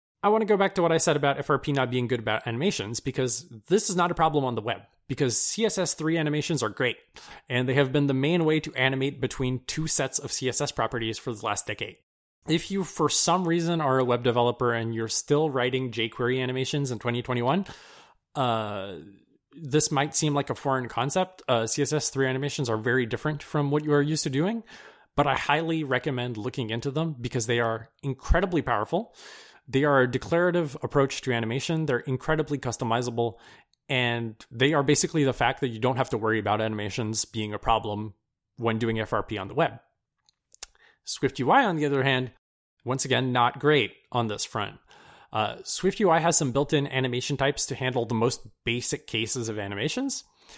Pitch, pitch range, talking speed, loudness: 130 Hz, 120-150 Hz, 190 wpm, -26 LUFS